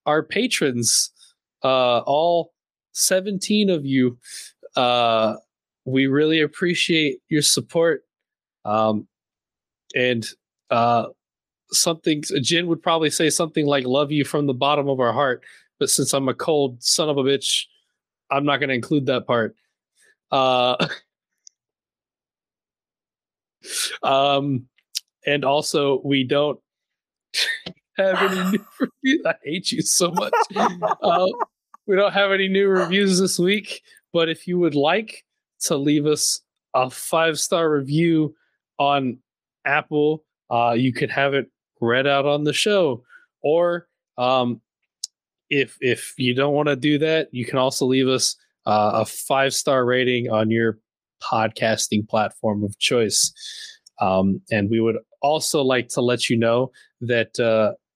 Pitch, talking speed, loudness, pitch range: 140 Hz, 140 wpm, -21 LUFS, 125-165 Hz